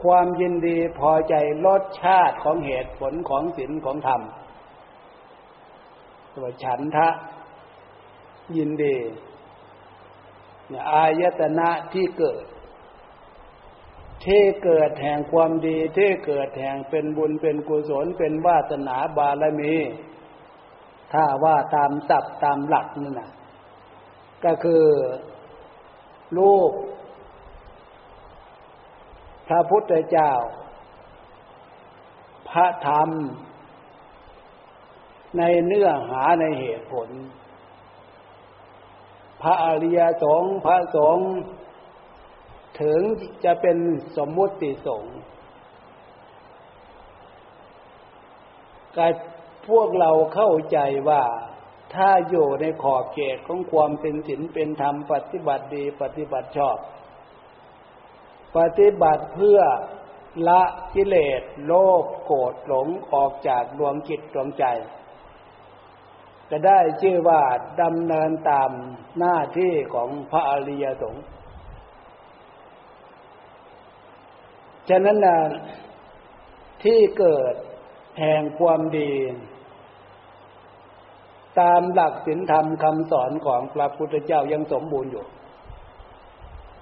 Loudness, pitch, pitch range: -21 LUFS, 160 Hz, 145-175 Hz